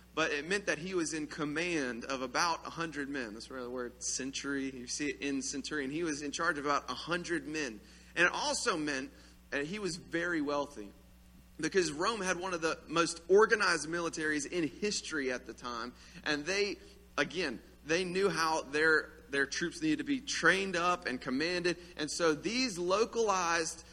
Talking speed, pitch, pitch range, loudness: 185 wpm, 160 Hz, 140-175 Hz, -33 LUFS